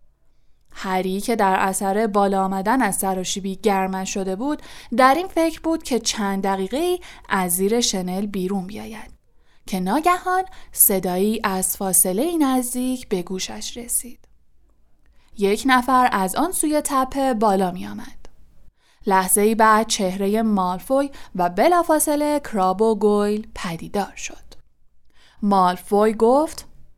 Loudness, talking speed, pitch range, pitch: -20 LUFS, 125 wpm, 190-260 Hz, 210 Hz